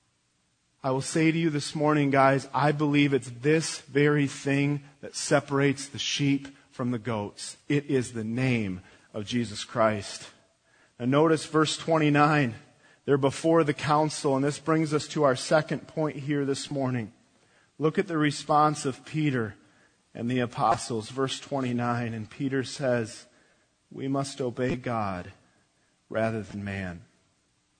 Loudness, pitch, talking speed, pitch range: -27 LUFS, 135 Hz, 145 wpm, 120-150 Hz